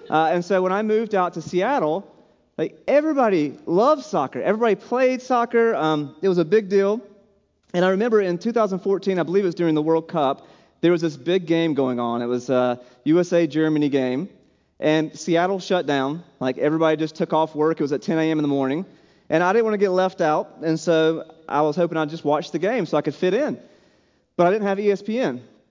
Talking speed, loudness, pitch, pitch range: 220 wpm, -21 LUFS, 170 Hz, 155-200 Hz